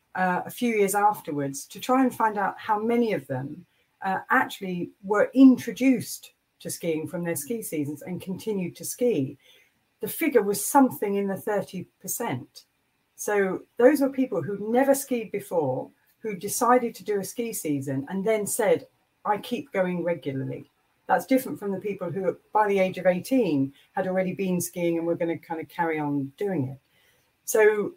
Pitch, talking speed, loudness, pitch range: 195 Hz, 180 wpm, -26 LUFS, 170-230 Hz